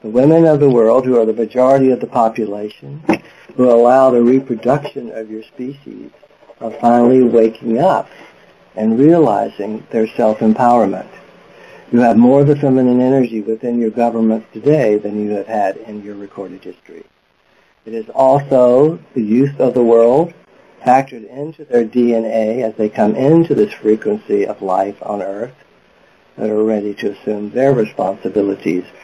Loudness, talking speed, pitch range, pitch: -14 LUFS, 155 wpm, 110-130 Hz, 115 Hz